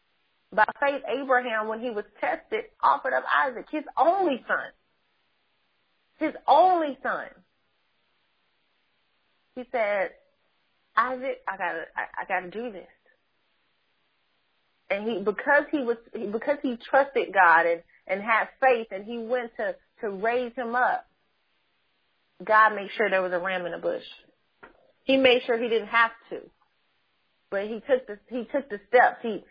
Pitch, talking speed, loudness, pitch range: 235 Hz, 150 wpm, -25 LUFS, 210-270 Hz